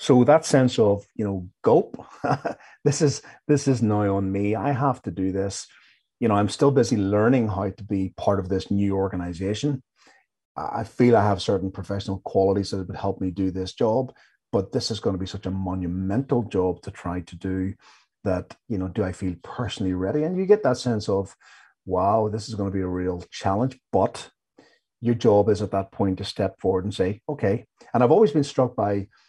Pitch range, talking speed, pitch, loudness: 95-120 Hz, 210 wpm, 100 Hz, -24 LUFS